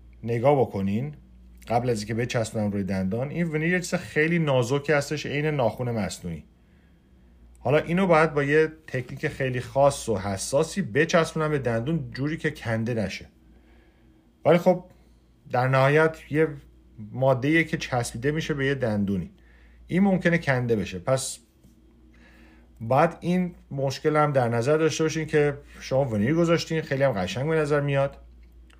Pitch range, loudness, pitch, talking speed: 105-155 Hz, -25 LUFS, 135 Hz, 145 wpm